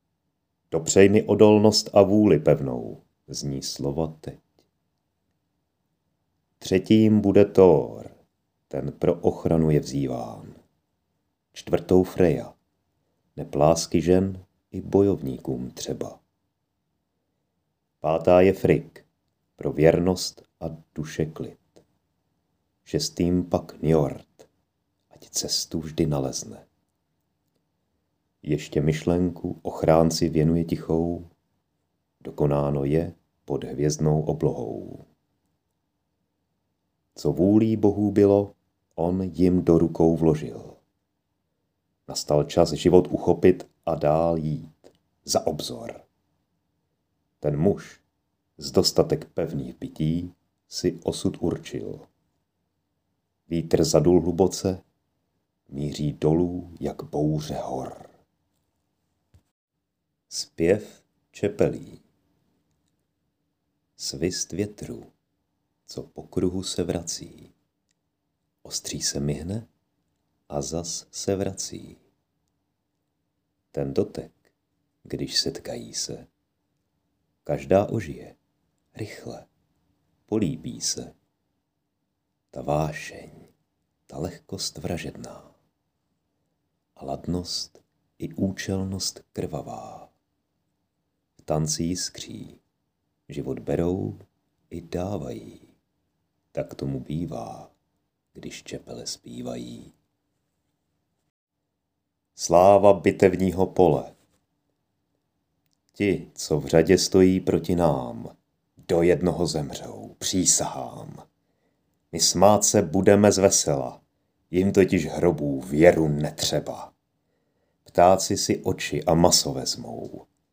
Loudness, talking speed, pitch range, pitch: -23 LUFS, 80 wpm, 75-95 Hz, 85 Hz